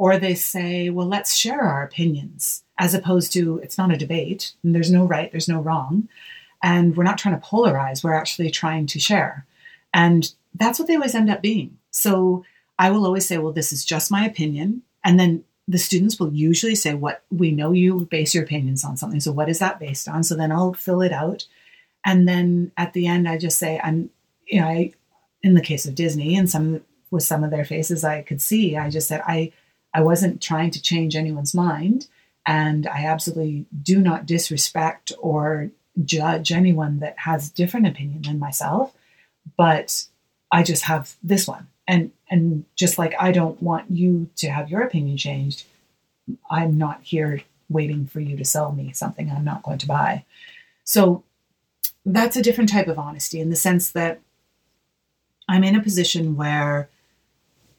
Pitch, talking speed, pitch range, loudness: 170 Hz, 190 wpm, 155-185 Hz, -21 LUFS